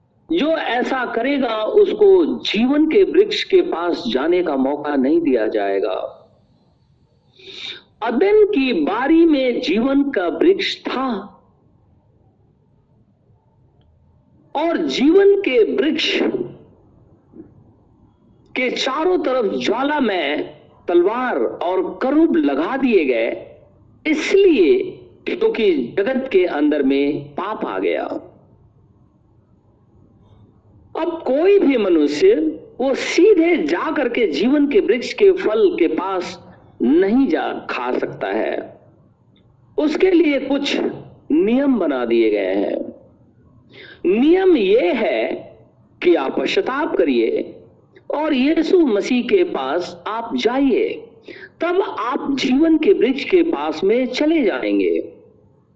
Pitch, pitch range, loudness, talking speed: 325 Hz, 260-375 Hz, -17 LUFS, 110 wpm